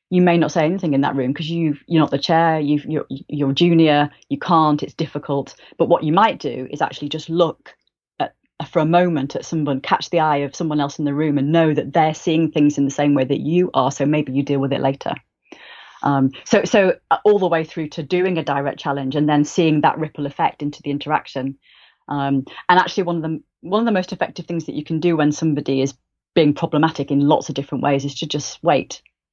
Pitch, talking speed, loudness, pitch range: 155 Hz, 235 wpm, -19 LUFS, 140-165 Hz